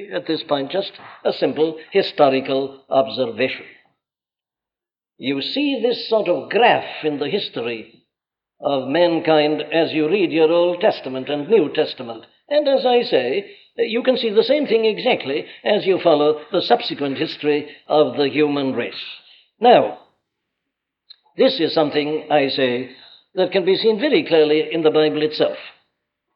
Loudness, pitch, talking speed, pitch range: -19 LUFS, 155 Hz, 150 wpm, 140-195 Hz